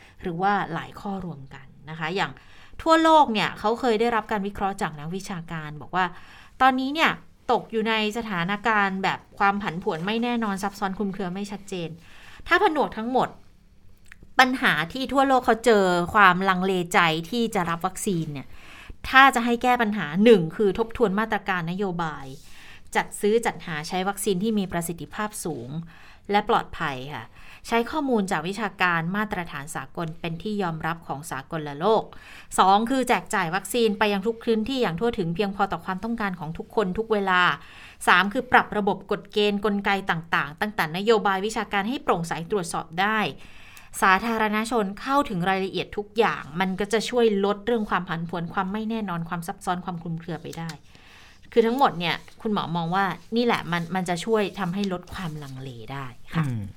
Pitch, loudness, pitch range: 195 Hz, -24 LUFS, 170-220 Hz